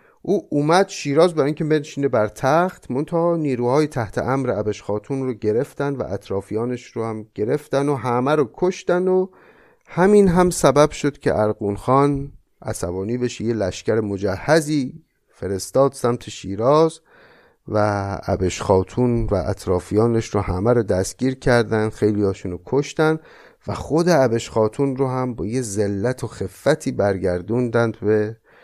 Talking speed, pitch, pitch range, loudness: 145 wpm, 125 Hz, 105-145 Hz, -20 LUFS